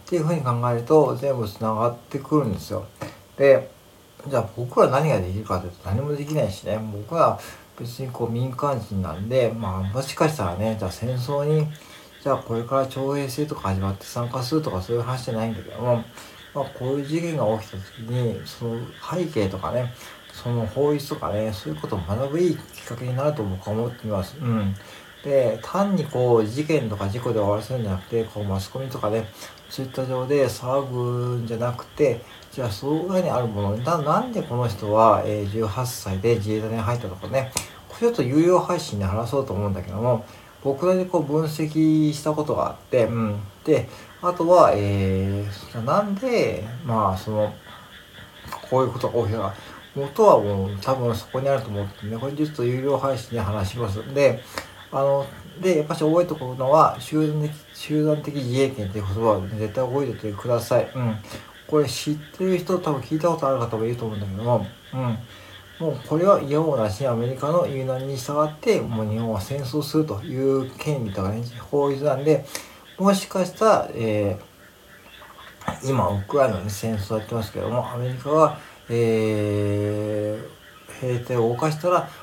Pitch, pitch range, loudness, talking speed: 120 Hz, 110-145 Hz, -24 LUFS, 370 characters per minute